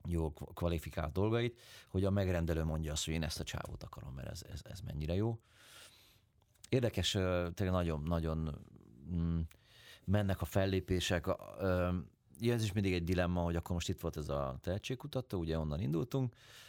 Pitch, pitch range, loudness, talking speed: 90 Hz, 85-105 Hz, -37 LUFS, 160 wpm